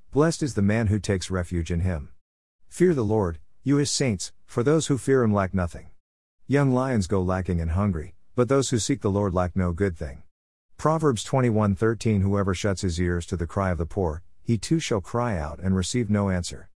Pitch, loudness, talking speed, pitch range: 100 Hz, -25 LUFS, 210 wpm, 90-120 Hz